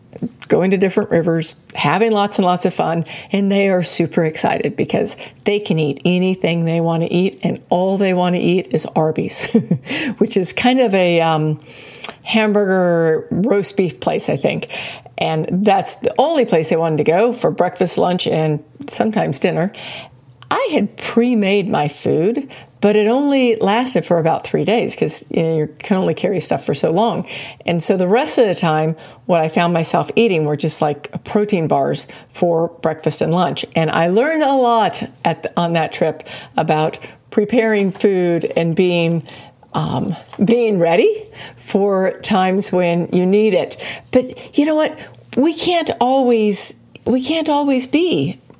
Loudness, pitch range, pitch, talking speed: -17 LUFS, 165-225 Hz, 185 Hz, 175 wpm